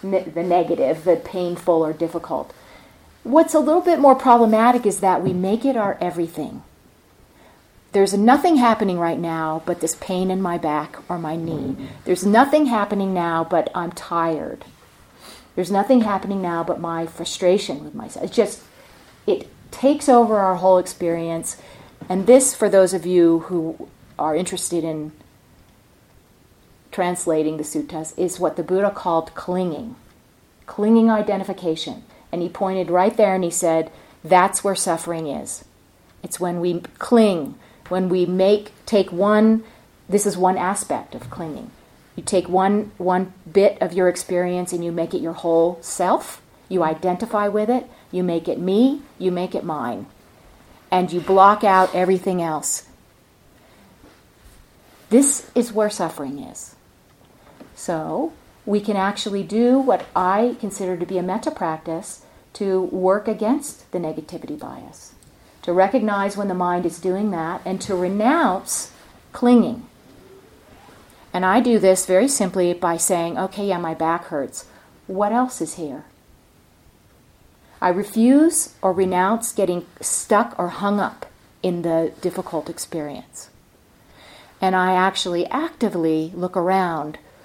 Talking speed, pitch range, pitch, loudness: 145 wpm, 170-205 Hz, 185 Hz, -20 LUFS